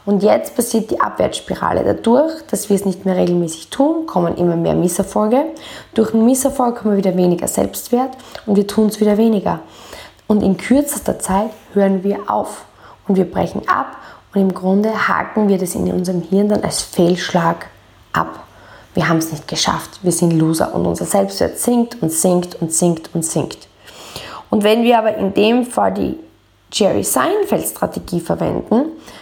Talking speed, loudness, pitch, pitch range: 175 wpm, -17 LUFS, 200 Hz, 180-230 Hz